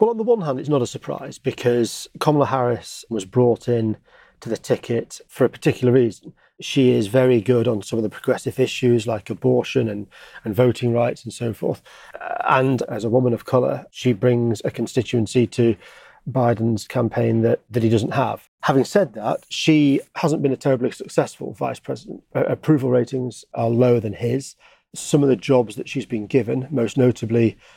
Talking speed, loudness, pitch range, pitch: 190 wpm, -21 LUFS, 115-130 Hz, 125 Hz